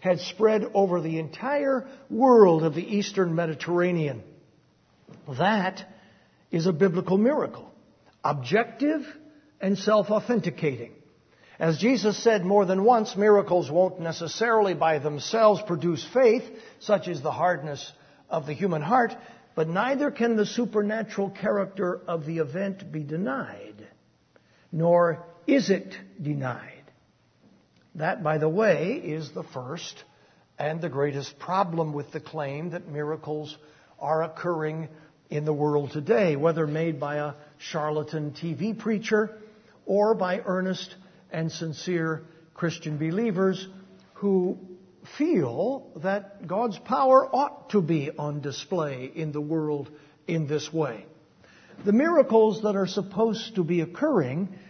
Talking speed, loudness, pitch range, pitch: 125 wpm, -26 LUFS, 155-210 Hz, 180 Hz